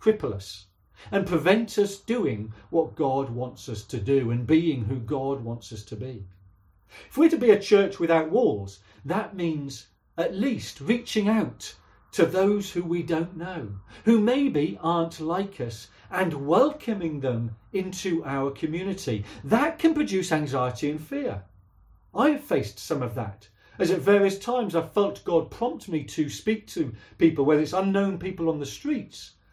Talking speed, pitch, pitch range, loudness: 170 wpm, 160 Hz, 115-195 Hz, -26 LUFS